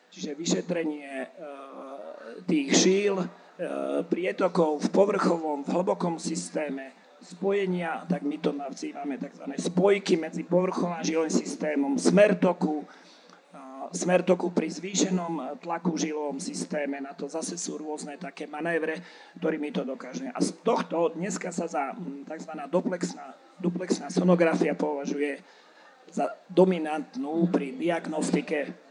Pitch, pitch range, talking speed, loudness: 165 Hz, 150-180 Hz, 115 wpm, -28 LUFS